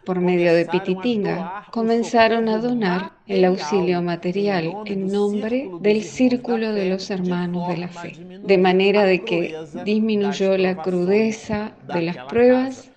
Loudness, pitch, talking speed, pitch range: -20 LUFS, 195 Hz, 140 wpm, 180-220 Hz